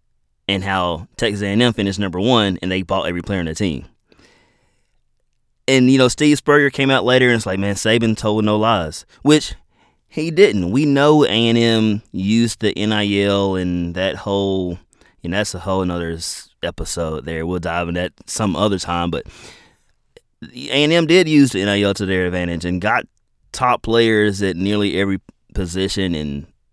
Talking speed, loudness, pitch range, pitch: 175 wpm, -17 LUFS, 90-115 Hz, 100 Hz